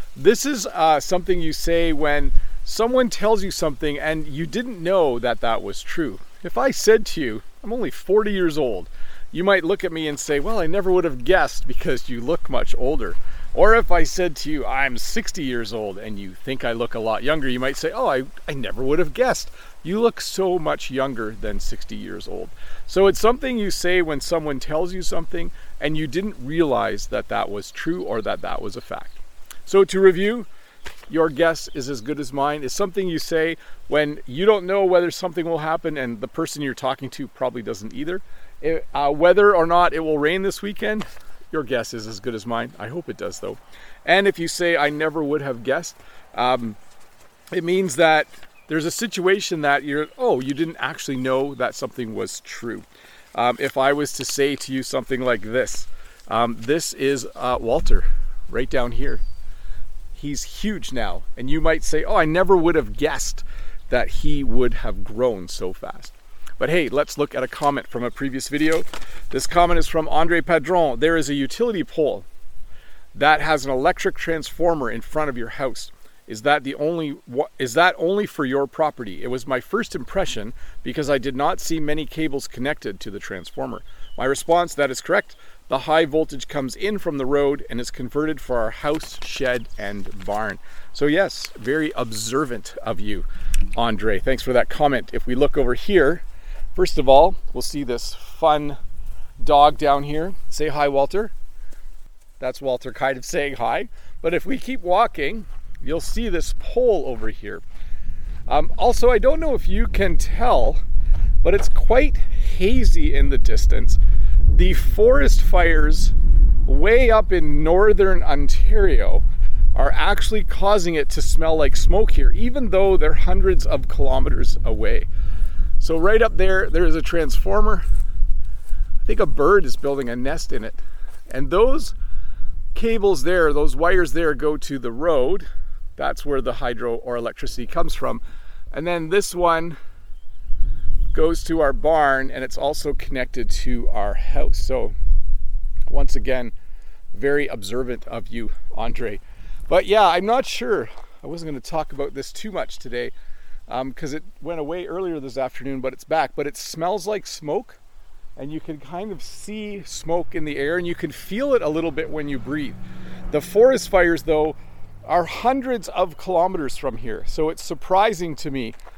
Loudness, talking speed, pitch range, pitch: -22 LUFS, 185 wpm, 130-175 Hz, 150 Hz